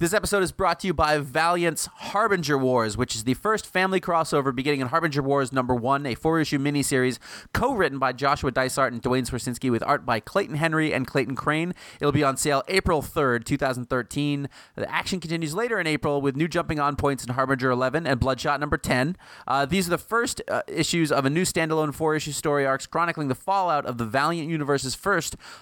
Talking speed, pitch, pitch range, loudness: 210 wpm, 145 Hz, 135-165 Hz, -24 LUFS